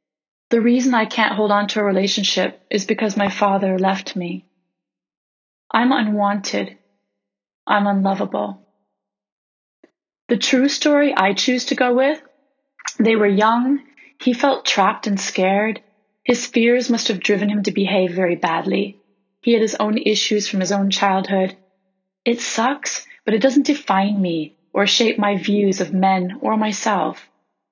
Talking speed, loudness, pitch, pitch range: 150 wpm, -18 LUFS, 205 Hz, 195-235 Hz